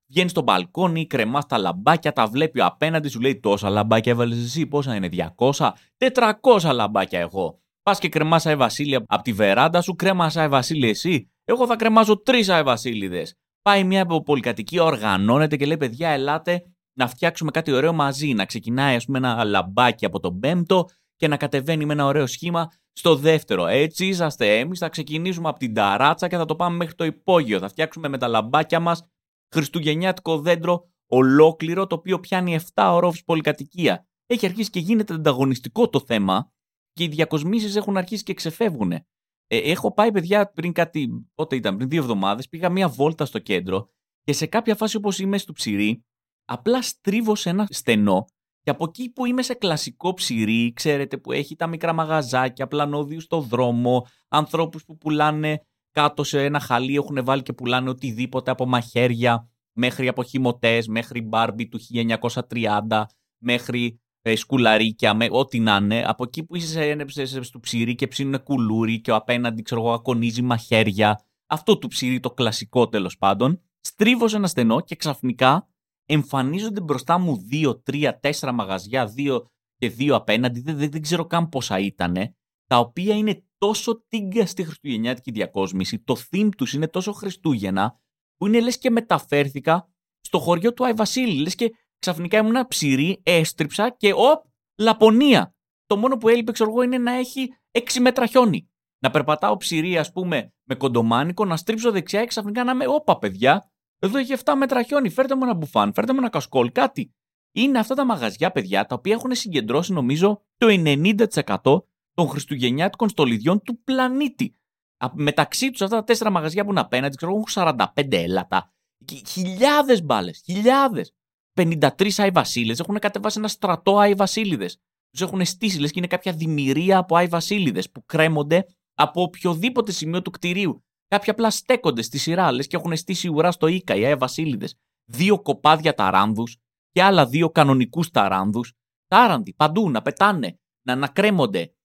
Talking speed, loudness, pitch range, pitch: 170 wpm, -21 LUFS, 125-195 Hz, 160 Hz